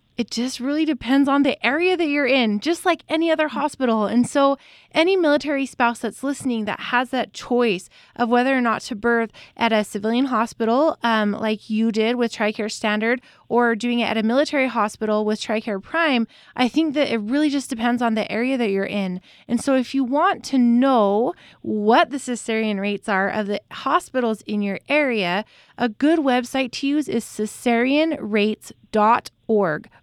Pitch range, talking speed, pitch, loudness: 220-275 Hz, 180 wpm, 240 Hz, -21 LUFS